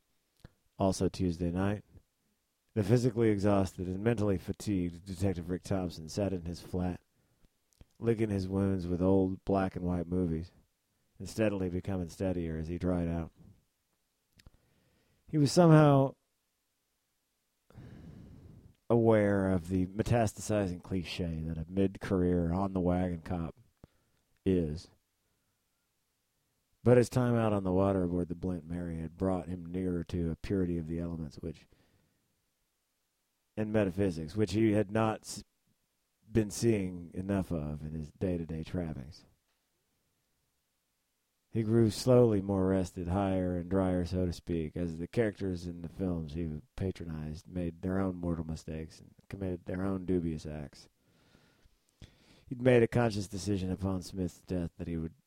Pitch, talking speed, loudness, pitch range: 95 Hz, 140 wpm, -32 LUFS, 85-100 Hz